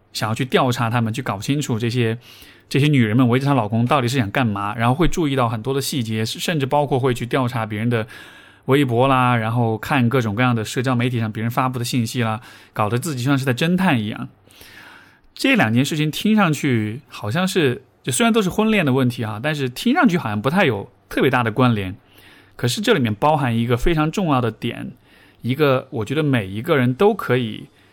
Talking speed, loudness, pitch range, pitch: 325 characters per minute, -19 LUFS, 115-140 Hz, 125 Hz